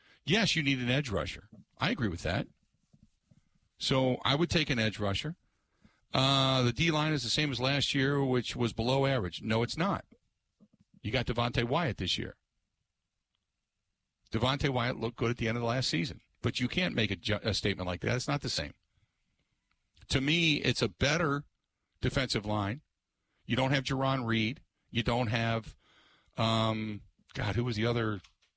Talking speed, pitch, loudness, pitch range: 180 wpm, 120 Hz, -31 LUFS, 110-135 Hz